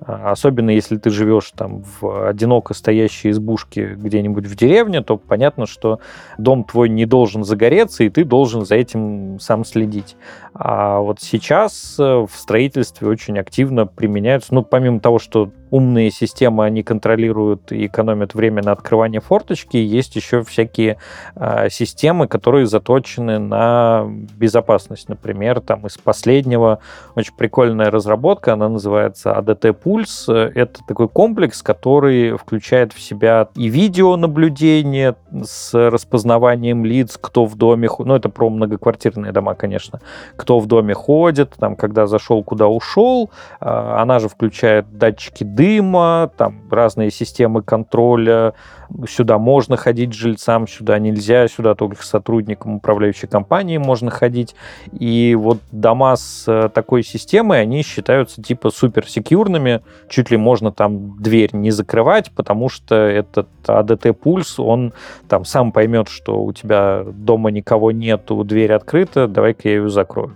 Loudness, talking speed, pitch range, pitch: -15 LUFS, 140 wpm, 110-125 Hz, 115 Hz